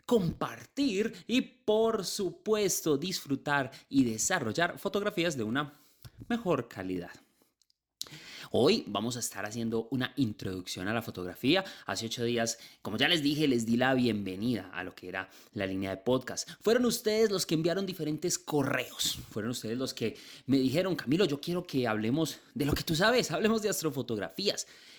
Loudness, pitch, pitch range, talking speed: -31 LUFS, 140 Hz, 115-180 Hz, 160 wpm